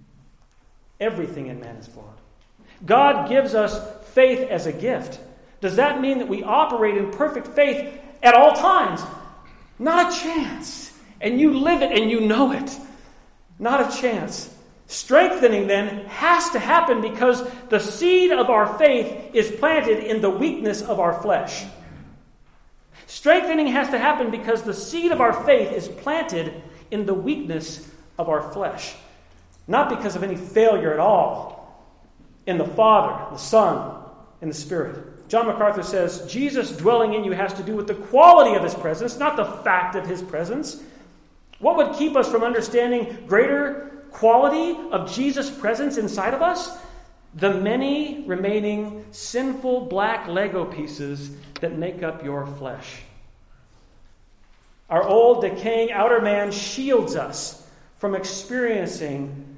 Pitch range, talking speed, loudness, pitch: 190-275 Hz, 150 wpm, -20 LUFS, 225 Hz